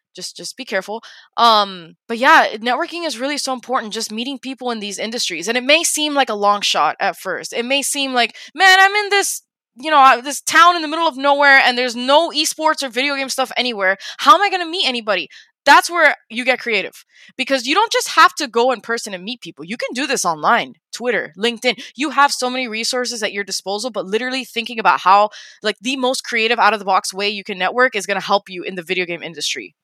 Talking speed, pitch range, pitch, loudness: 240 wpm, 210-280 Hz, 250 Hz, -16 LUFS